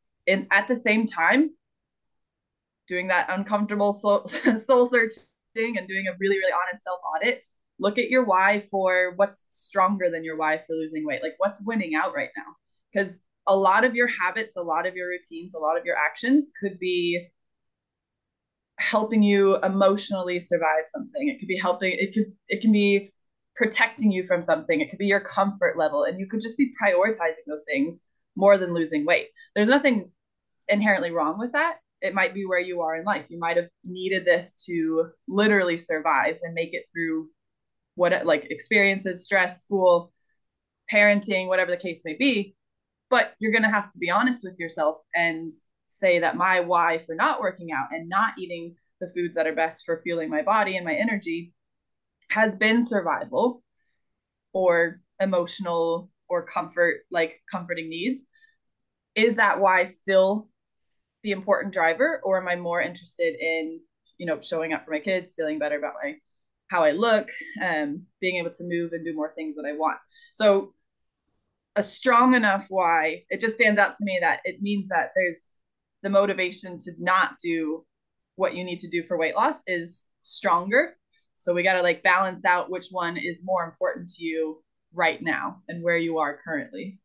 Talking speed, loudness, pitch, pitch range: 180 wpm, -24 LUFS, 185 Hz, 170-210 Hz